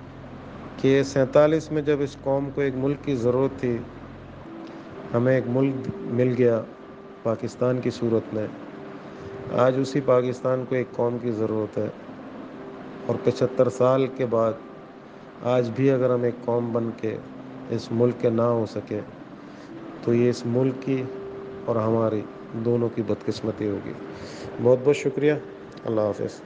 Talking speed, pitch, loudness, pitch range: 145 wpm, 120 Hz, -24 LUFS, 110-130 Hz